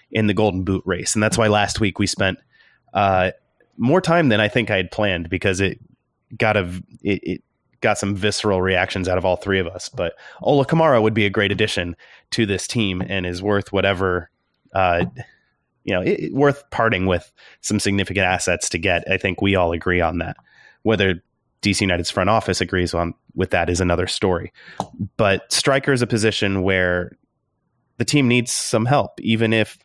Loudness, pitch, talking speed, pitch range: -20 LUFS, 100 Hz, 195 wpm, 90-110 Hz